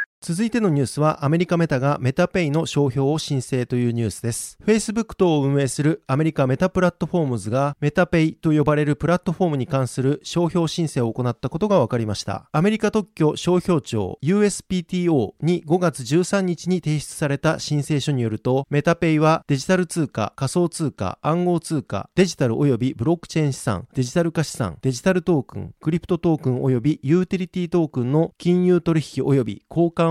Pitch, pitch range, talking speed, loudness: 155 Hz, 135-175 Hz, 425 characters per minute, -21 LUFS